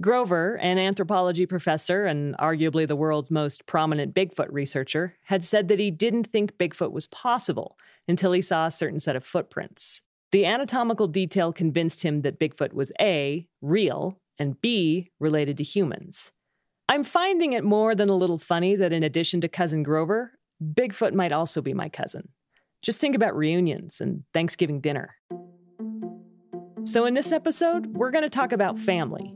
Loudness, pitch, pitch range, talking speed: -25 LUFS, 180 Hz, 160-210 Hz, 165 wpm